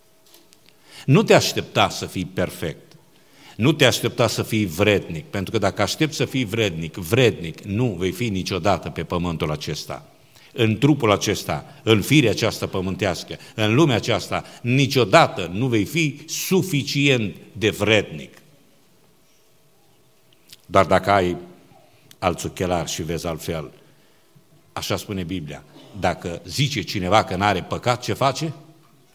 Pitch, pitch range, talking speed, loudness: 110 Hz, 95-135 Hz, 130 wpm, -21 LUFS